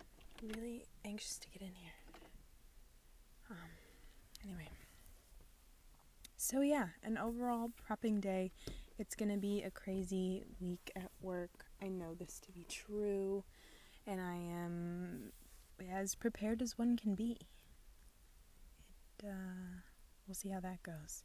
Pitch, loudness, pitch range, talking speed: 195 Hz, -43 LUFS, 180-215 Hz, 125 wpm